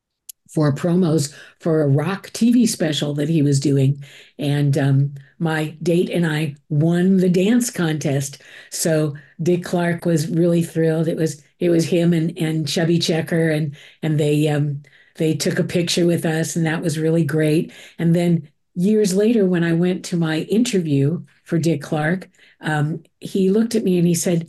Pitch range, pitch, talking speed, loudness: 155-175 Hz, 165 Hz, 175 wpm, -19 LUFS